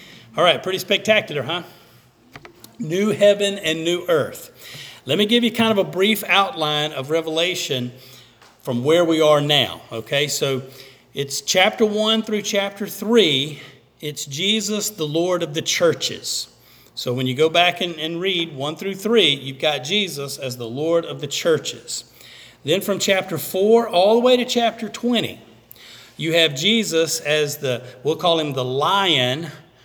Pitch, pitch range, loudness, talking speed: 165 Hz, 140-200 Hz, -19 LUFS, 165 wpm